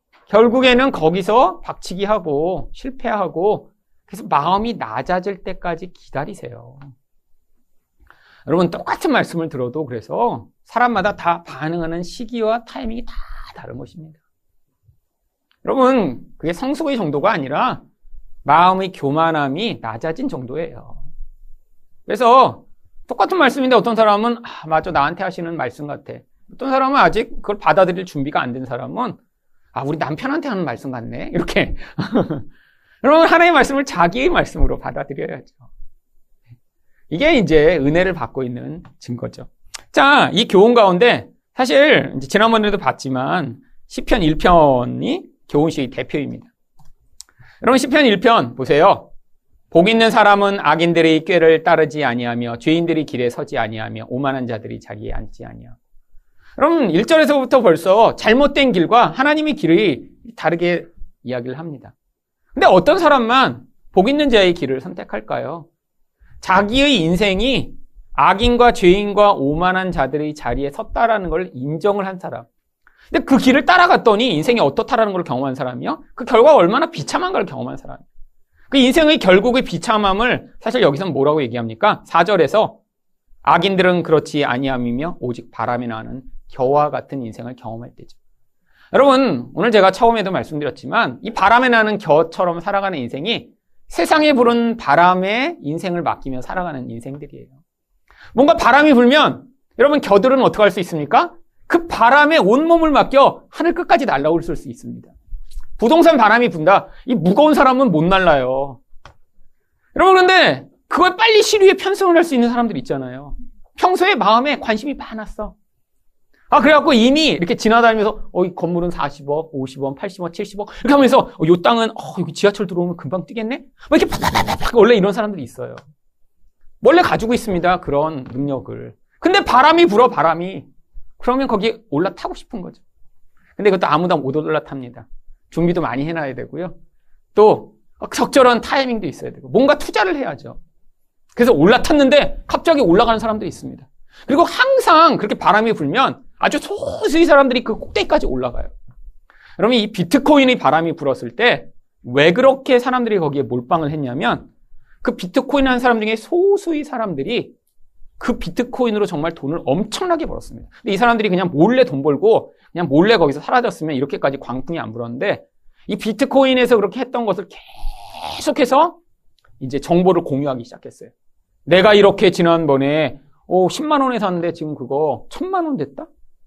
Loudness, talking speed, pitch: -15 LUFS, 340 characters per minute, 195 Hz